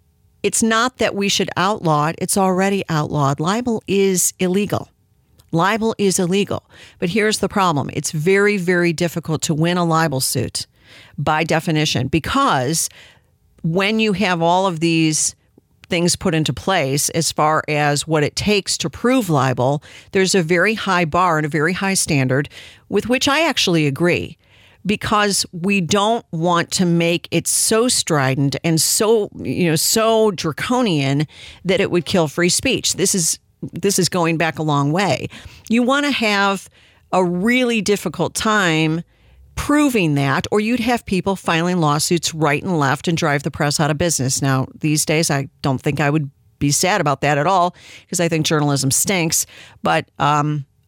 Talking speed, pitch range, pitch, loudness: 170 wpm, 150-195 Hz, 170 Hz, -17 LUFS